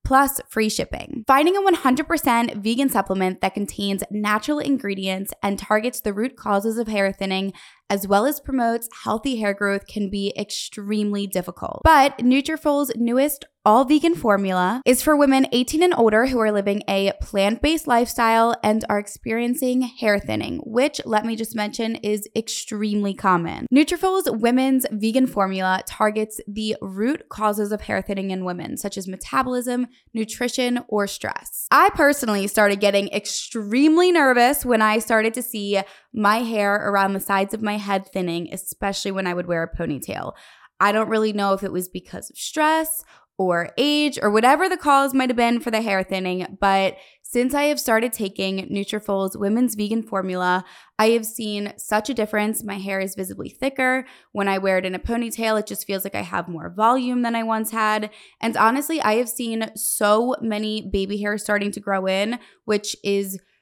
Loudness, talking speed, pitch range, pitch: -21 LUFS, 175 wpm, 200-250 Hz, 215 Hz